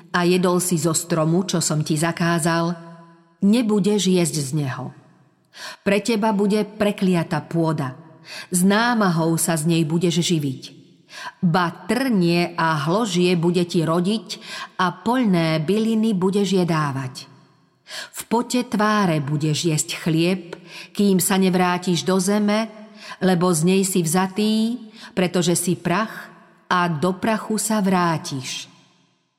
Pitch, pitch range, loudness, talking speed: 180 Hz, 165-205 Hz, -20 LUFS, 125 wpm